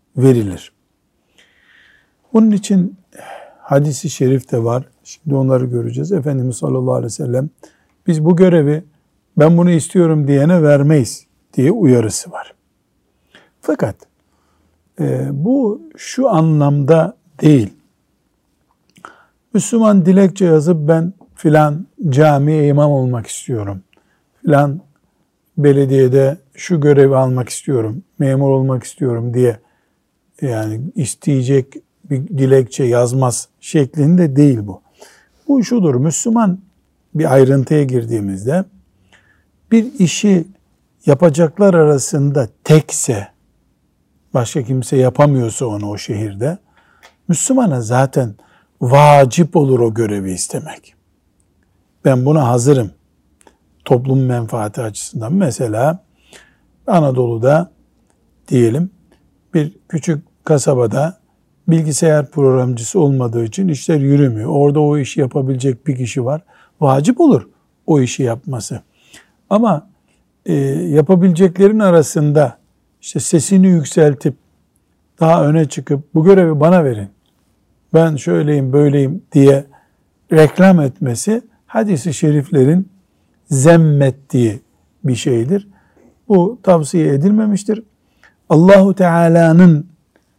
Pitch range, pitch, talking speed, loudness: 130-170 Hz, 145 Hz, 95 wpm, -14 LUFS